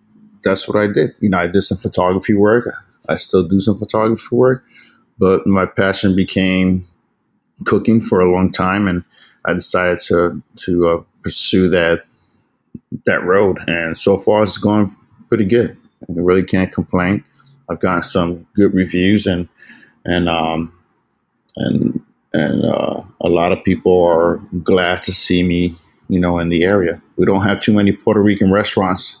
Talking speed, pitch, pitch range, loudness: 165 wpm, 95 Hz, 90-105 Hz, -15 LUFS